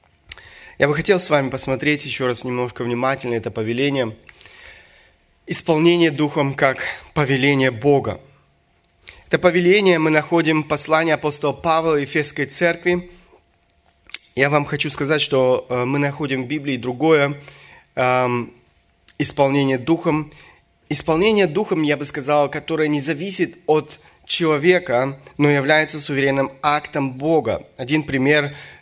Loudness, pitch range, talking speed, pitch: -18 LUFS, 130-155 Hz, 120 wpm, 145 Hz